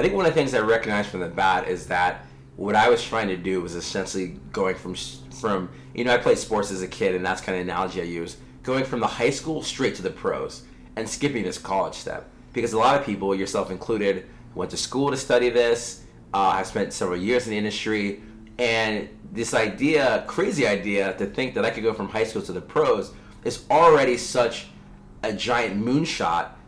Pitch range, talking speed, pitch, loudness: 90-120 Hz, 220 wpm, 105 Hz, -24 LUFS